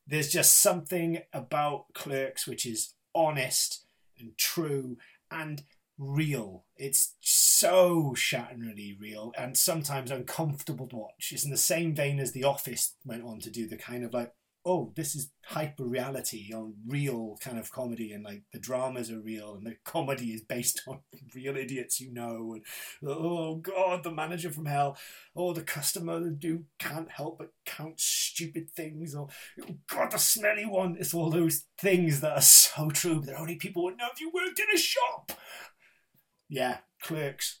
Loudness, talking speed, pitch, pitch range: -27 LUFS, 170 wpm, 145 Hz, 125-165 Hz